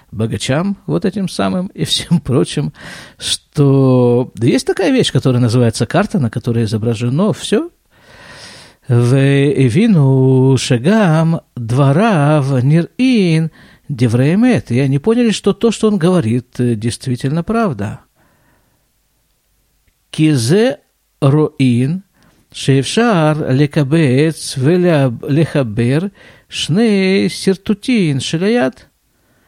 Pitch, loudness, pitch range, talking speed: 150 Hz, -14 LUFS, 130-195 Hz, 90 wpm